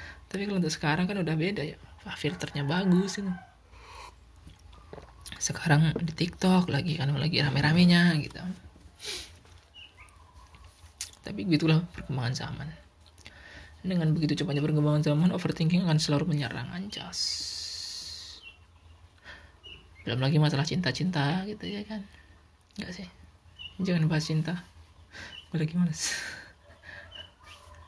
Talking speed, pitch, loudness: 110 wpm, 145 Hz, -28 LUFS